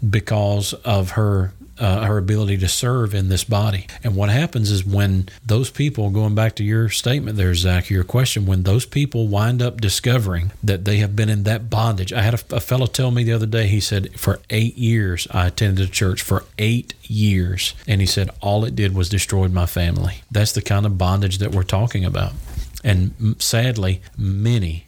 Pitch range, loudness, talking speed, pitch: 95-115 Hz, -19 LUFS, 205 wpm, 105 Hz